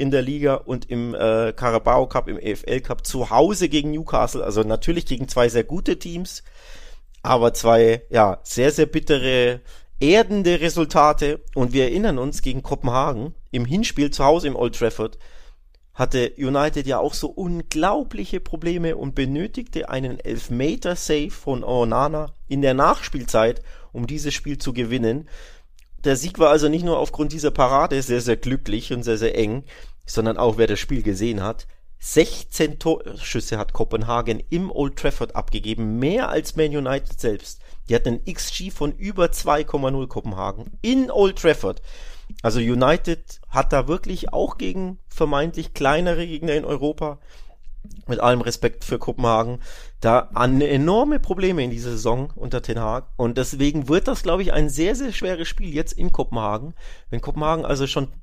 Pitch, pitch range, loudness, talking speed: 140 Hz, 120-160 Hz, -22 LUFS, 160 wpm